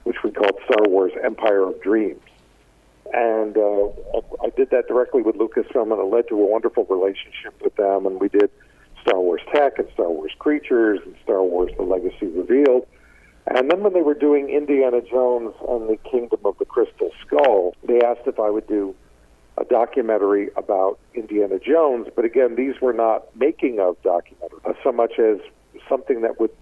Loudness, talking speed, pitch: -20 LUFS, 185 wpm, 145 Hz